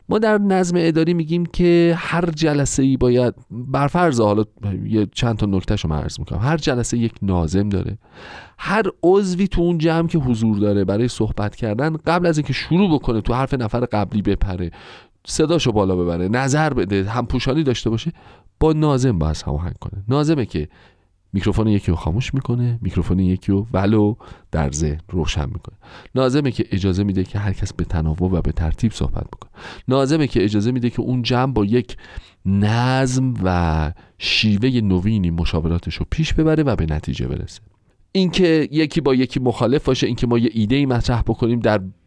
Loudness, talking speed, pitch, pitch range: -19 LUFS, 175 wpm, 115 Hz, 95-135 Hz